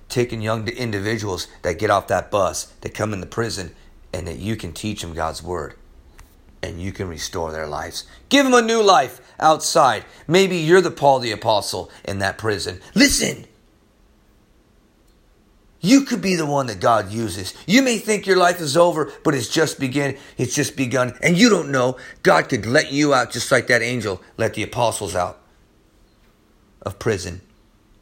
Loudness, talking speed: -19 LUFS, 180 wpm